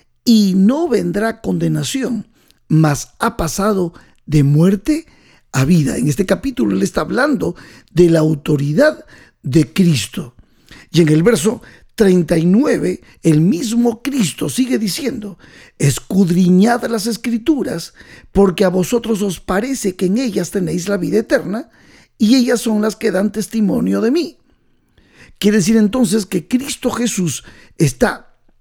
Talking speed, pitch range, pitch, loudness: 130 wpm, 170-235 Hz, 205 Hz, -16 LUFS